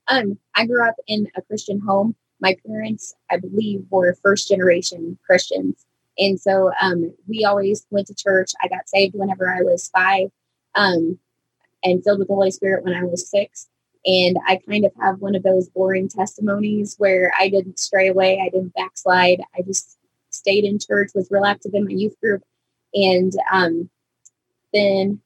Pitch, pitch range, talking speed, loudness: 195 Hz, 185-205 Hz, 180 wpm, -19 LUFS